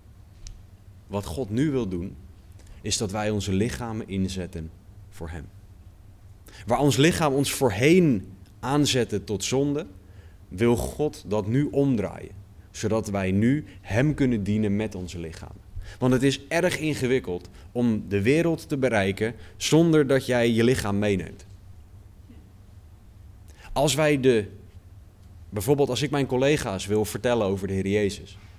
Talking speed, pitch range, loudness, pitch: 135 wpm, 95-130 Hz, -24 LUFS, 100 Hz